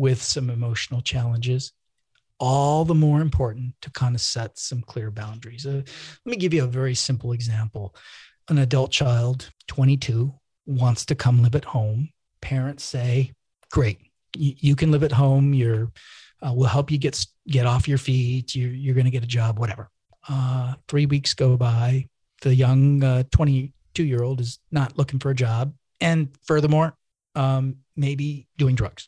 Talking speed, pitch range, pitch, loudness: 170 wpm, 120-140 Hz, 130 Hz, -23 LUFS